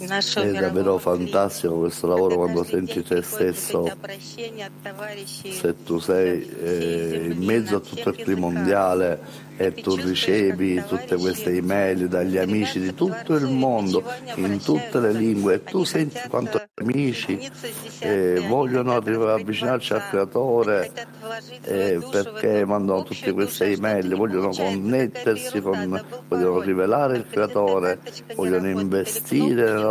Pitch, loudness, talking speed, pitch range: 95 Hz, -23 LUFS, 125 wpm, 90-115 Hz